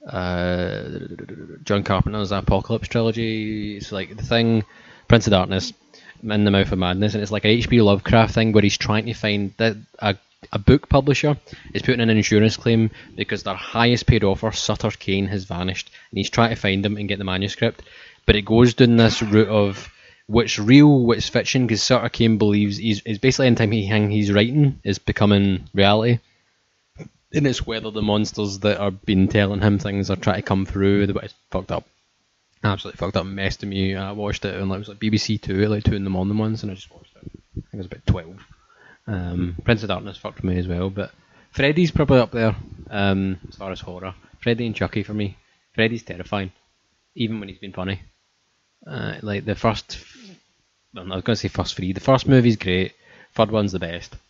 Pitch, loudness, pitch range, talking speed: 105 Hz, -20 LUFS, 95-115 Hz, 205 wpm